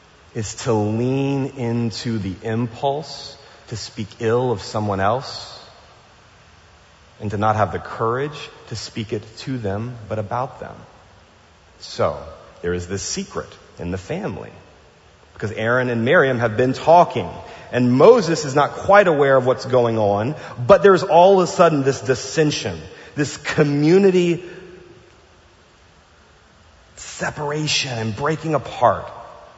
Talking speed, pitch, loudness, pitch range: 130 wpm, 120 Hz, -19 LUFS, 105-145 Hz